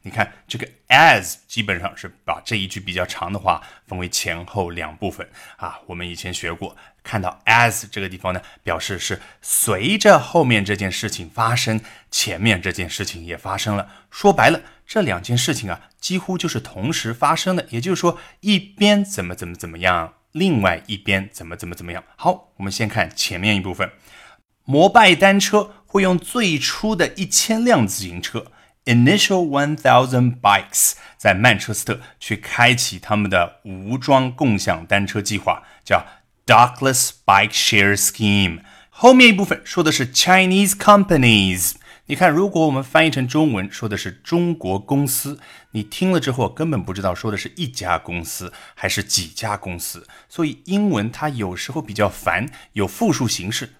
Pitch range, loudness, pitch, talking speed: 95-160 Hz, -18 LUFS, 115 Hz, 310 characters per minute